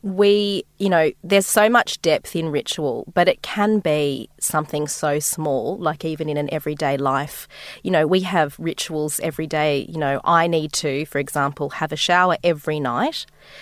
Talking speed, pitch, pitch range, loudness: 180 wpm, 155 Hz, 150-180 Hz, -20 LUFS